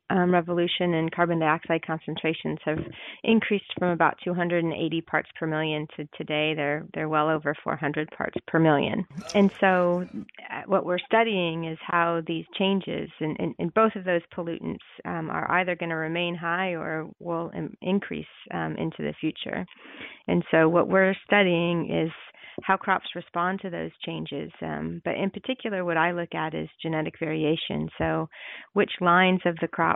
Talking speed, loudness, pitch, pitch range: 170 wpm, -26 LUFS, 170 Hz, 155-180 Hz